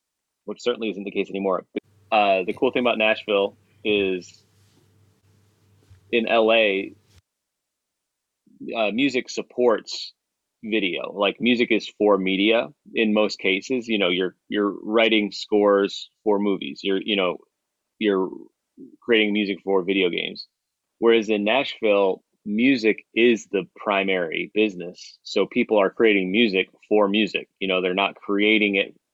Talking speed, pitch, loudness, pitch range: 135 wpm, 105 Hz, -22 LUFS, 100-110 Hz